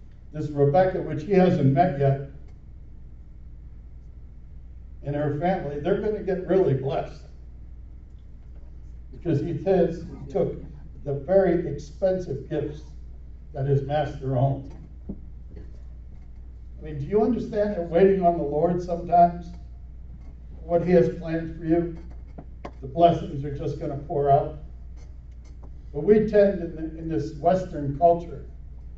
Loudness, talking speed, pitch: -24 LUFS, 135 wpm, 140 Hz